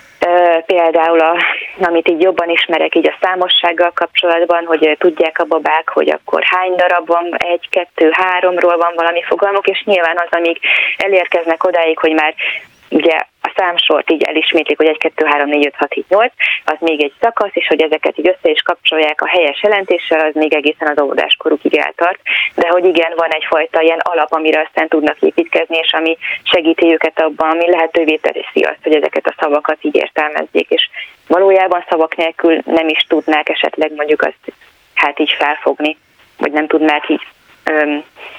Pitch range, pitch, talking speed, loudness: 155-175 Hz, 165 Hz, 175 wpm, -13 LUFS